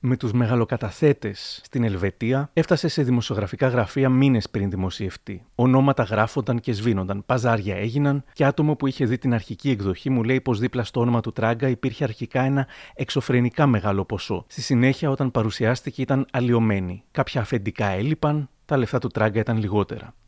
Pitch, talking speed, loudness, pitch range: 125 Hz, 165 wpm, -23 LUFS, 110-135 Hz